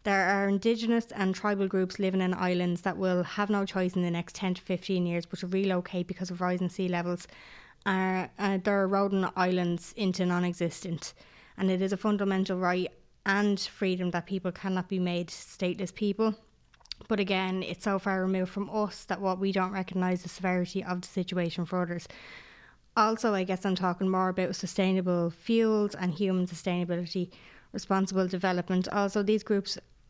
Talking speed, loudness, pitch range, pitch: 175 wpm, -30 LUFS, 180-195 Hz, 185 Hz